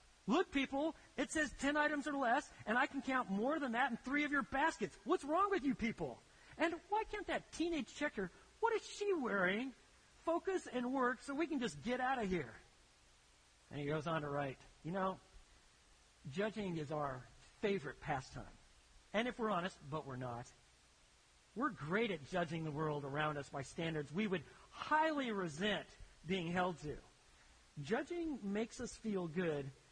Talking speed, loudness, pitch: 175 wpm, -40 LUFS, 205 Hz